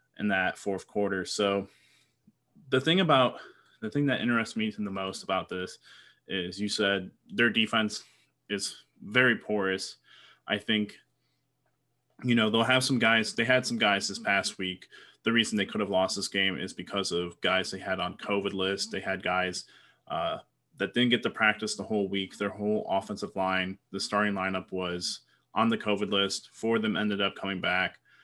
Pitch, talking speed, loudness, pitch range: 105 Hz, 185 wpm, -29 LUFS, 95-115 Hz